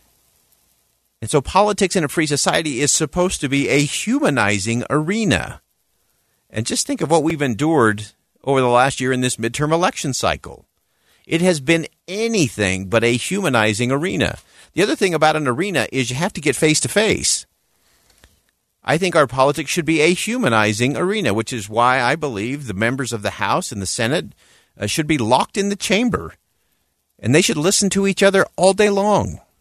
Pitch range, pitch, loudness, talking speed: 120-185 Hz, 145 Hz, -18 LUFS, 180 wpm